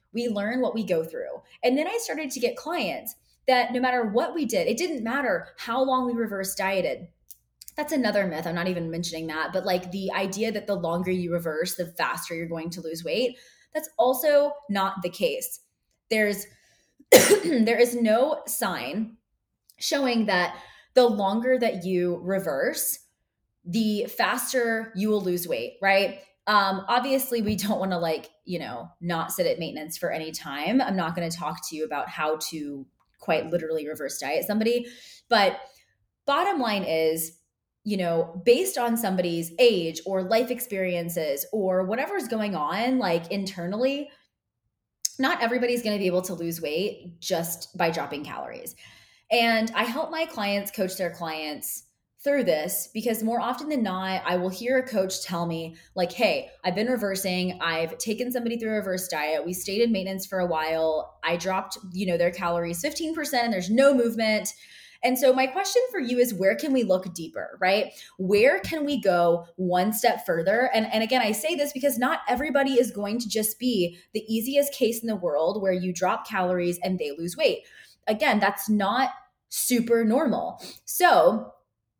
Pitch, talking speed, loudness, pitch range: 210 Hz, 180 wpm, -25 LUFS, 180-250 Hz